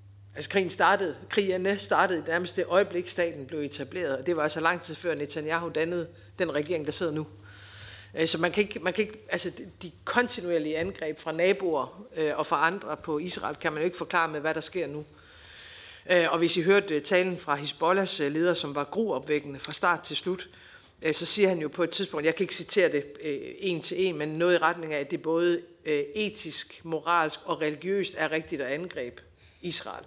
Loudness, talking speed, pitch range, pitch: -28 LUFS, 200 wpm, 150-180 Hz, 165 Hz